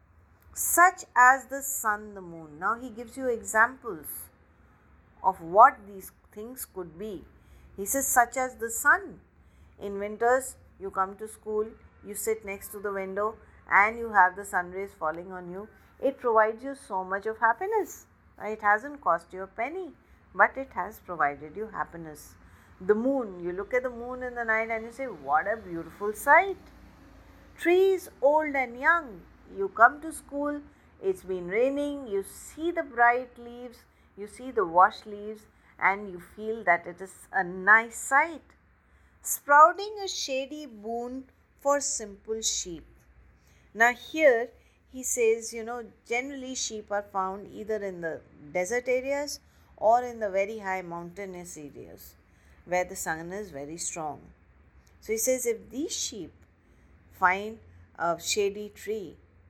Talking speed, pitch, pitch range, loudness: 155 wpm, 220 Hz, 185-255 Hz, -27 LUFS